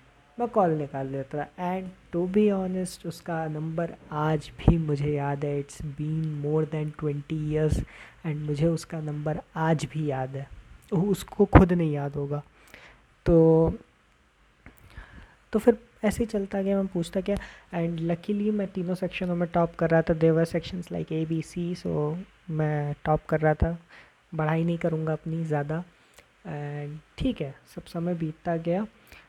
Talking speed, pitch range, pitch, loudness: 160 wpm, 150-180 Hz, 165 Hz, -27 LUFS